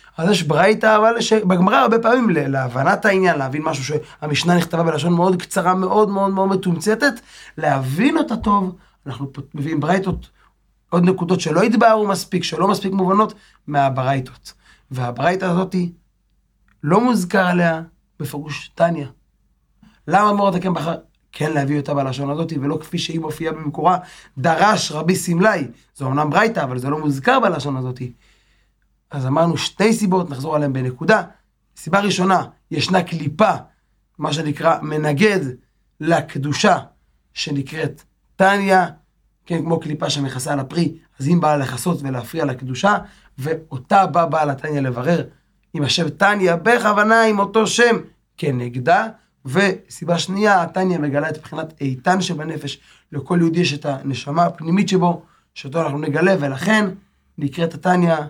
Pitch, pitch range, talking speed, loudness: 165 Hz, 145-190 Hz, 140 wpm, -18 LUFS